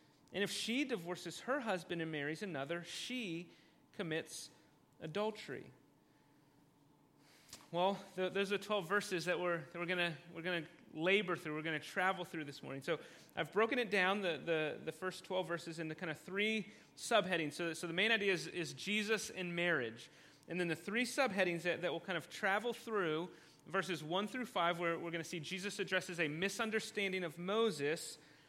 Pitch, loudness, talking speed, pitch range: 175 Hz, -39 LUFS, 185 wpm, 165-200 Hz